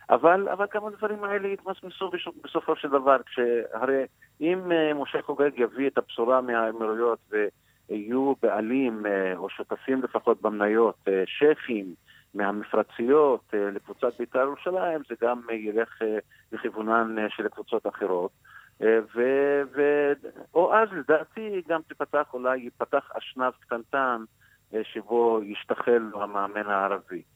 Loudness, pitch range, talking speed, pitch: -26 LUFS, 110-145 Hz, 105 wpm, 125 Hz